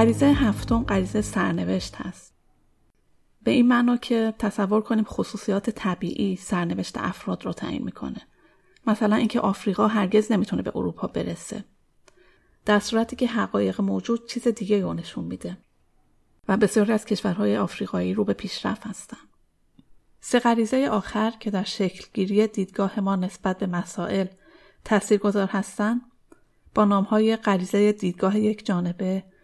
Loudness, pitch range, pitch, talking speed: -24 LUFS, 190-220 Hz, 205 Hz, 130 wpm